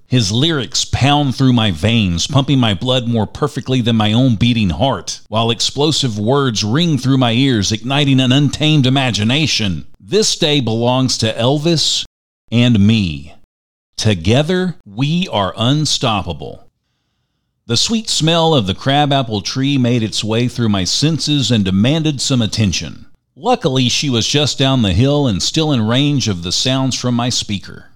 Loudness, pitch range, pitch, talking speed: -14 LUFS, 105-140 Hz, 125 Hz, 155 wpm